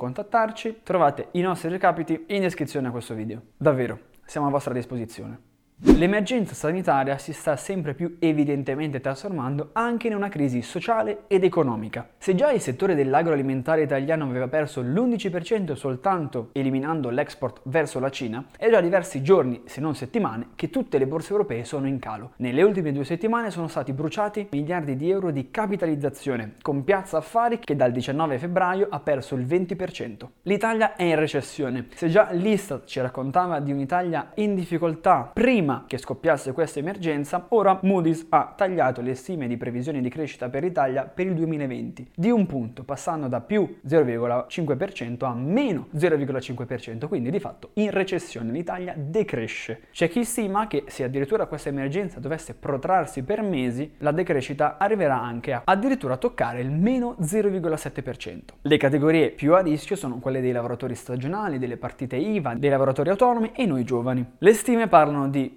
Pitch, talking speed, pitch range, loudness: 150 Hz, 165 wpm, 130-190 Hz, -24 LUFS